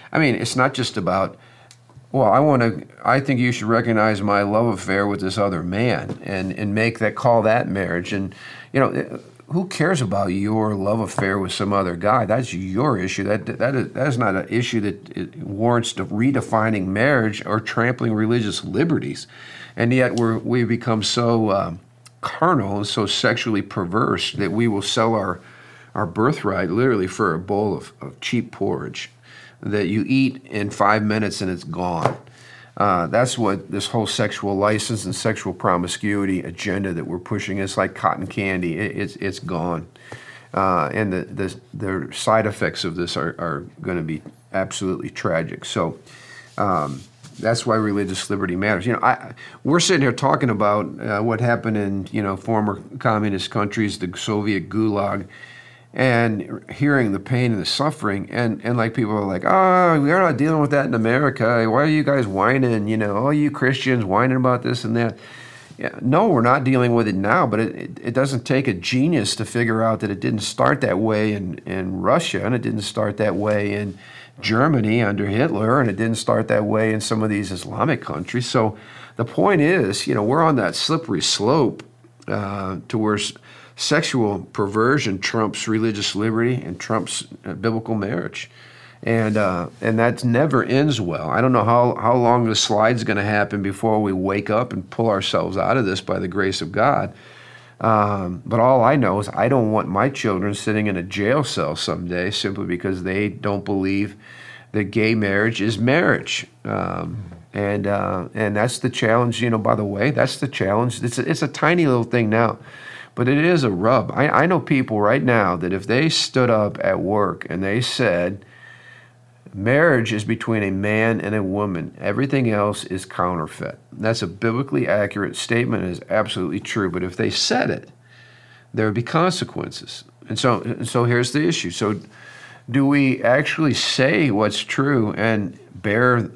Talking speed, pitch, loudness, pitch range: 185 wpm, 110 Hz, -20 LUFS, 100-125 Hz